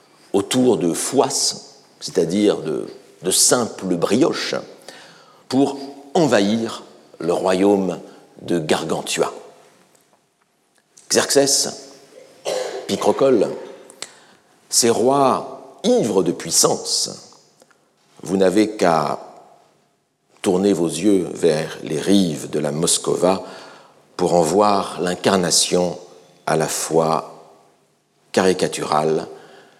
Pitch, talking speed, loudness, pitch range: 105 Hz, 85 wpm, -19 LUFS, 90-140 Hz